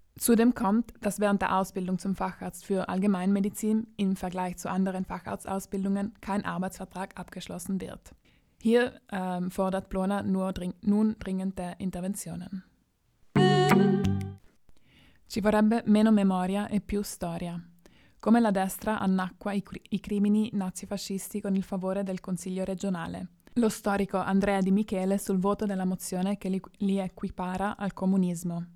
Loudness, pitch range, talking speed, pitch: -29 LUFS, 185-205 Hz, 135 wpm, 195 Hz